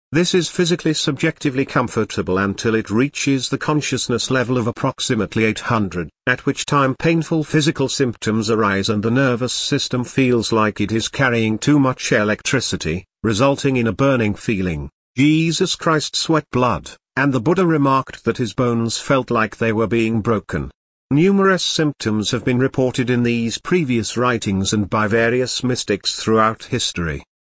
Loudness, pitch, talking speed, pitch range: -18 LUFS, 125 Hz, 150 wpm, 110-140 Hz